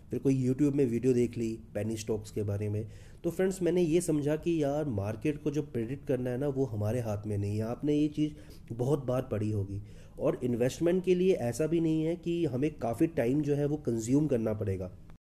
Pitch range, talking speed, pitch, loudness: 110-150 Hz, 225 wpm, 125 Hz, -31 LUFS